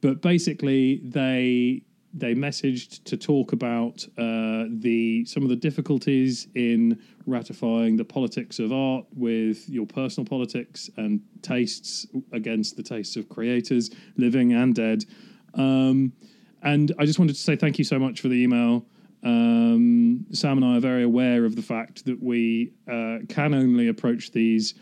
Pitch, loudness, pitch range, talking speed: 130 Hz, -24 LUFS, 120-155 Hz, 155 wpm